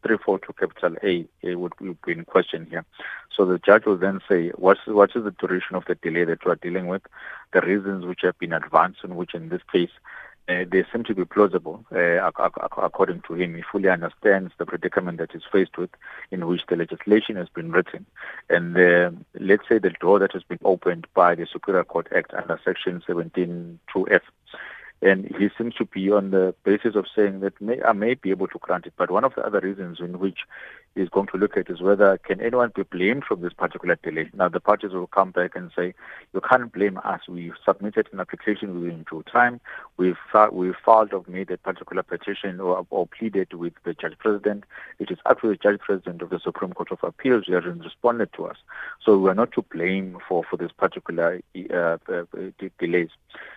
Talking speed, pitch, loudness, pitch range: 215 wpm, 95 Hz, -23 LUFS, 90-100 Hz